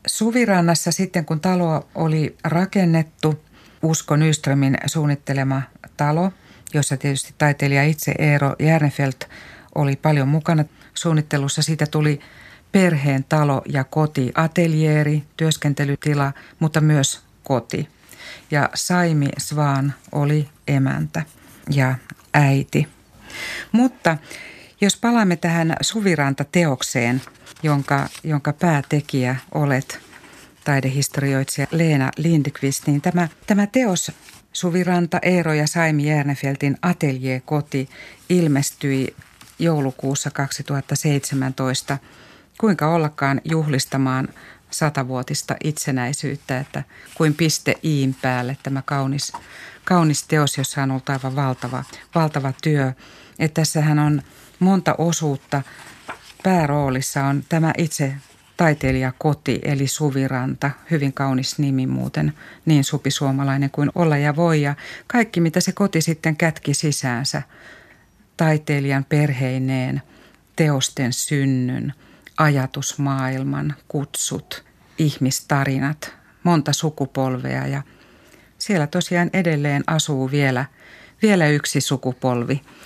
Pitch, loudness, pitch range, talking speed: 145 Hz, -20 LUFS, 135-160 Hz, 95 wpm